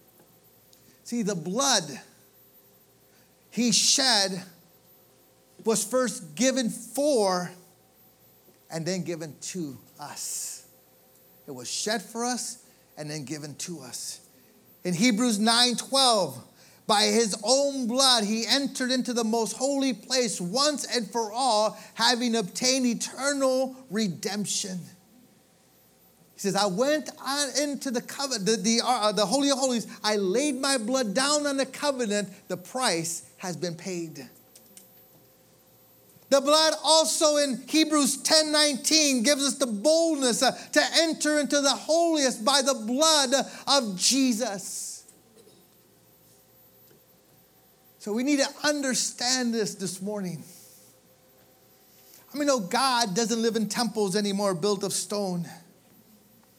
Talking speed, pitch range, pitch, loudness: 120 wpm, 195-270 Hz, 235 Hz, -25 LUFS